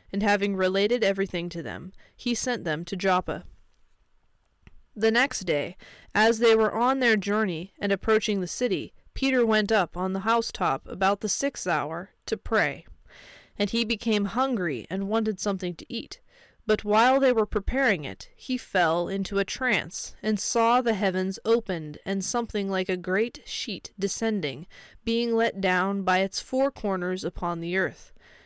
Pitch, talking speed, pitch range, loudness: 210 Hz, 165 wpm, 190-230 Hz, -26 LUFS